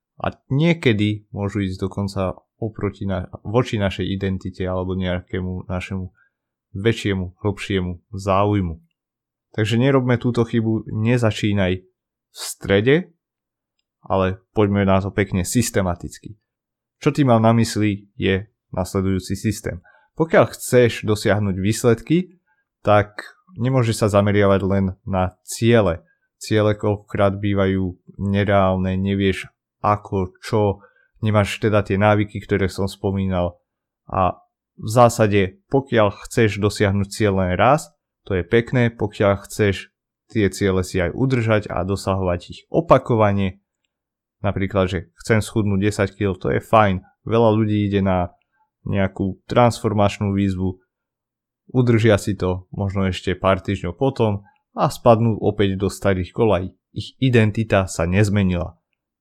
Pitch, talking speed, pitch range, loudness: 100 Hz, 120 wpm, 95-115 Hz, -20 LUFS